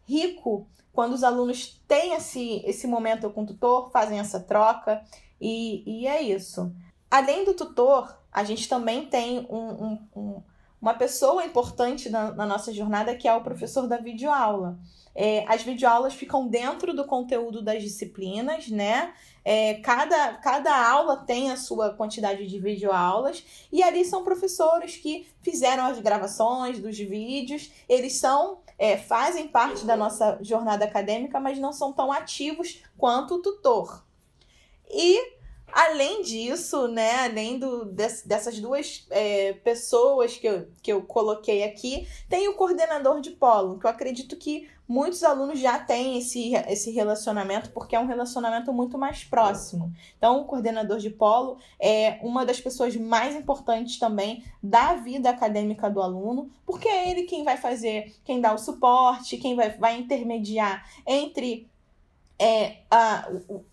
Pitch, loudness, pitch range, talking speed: 240 Hz, -25 LUFS, 215-280 Hz, 155 wpm